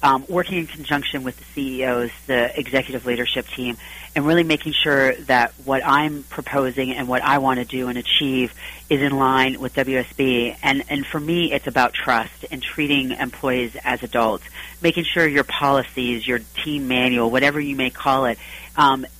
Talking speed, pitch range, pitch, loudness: 180 wpm, 125-145 Hz, 135 Hz, -20 LUFS